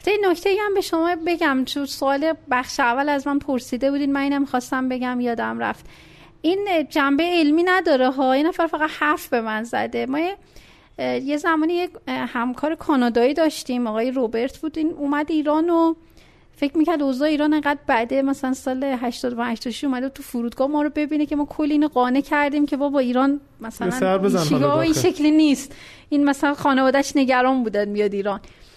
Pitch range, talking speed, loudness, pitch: 250-305 Hz, 175 wpm, -21 LUFS, 280 Hz